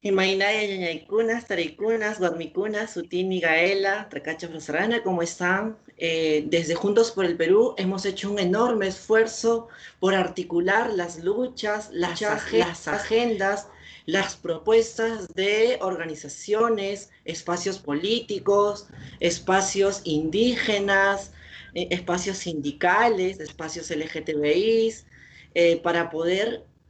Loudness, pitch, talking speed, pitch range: -24 LUFS, 190 Hz, 105 wpm, 170-210 Hz